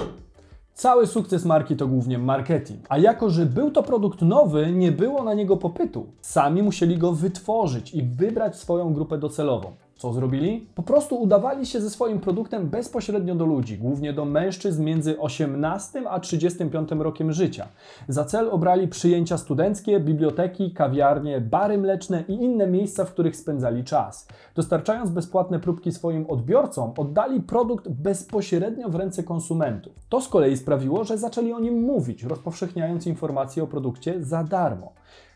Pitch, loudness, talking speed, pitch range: 175 Hz, -23 LUFS, 155 wpm, 155-200 Hz